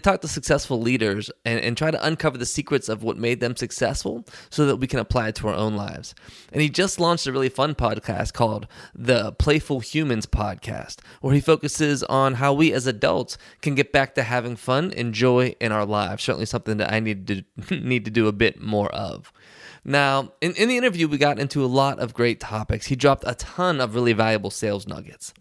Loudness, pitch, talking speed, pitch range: -23 LUFS, 125 Hz, 220 wpm, 110-145 Hz